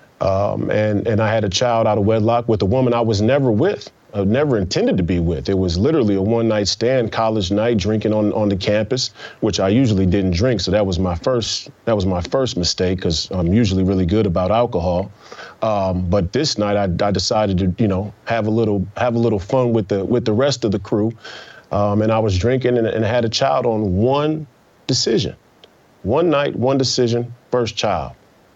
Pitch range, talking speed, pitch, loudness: 95-120 Hz, 215 wpm, 110 Hz, -18 LUFS